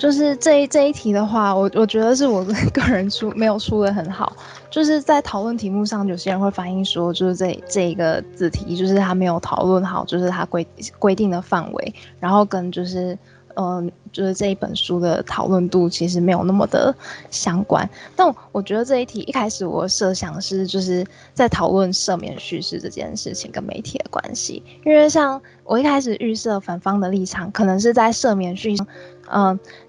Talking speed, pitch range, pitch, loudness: 295 characters per minute, 185-225 Hz, 195 Hz, -19 LUFS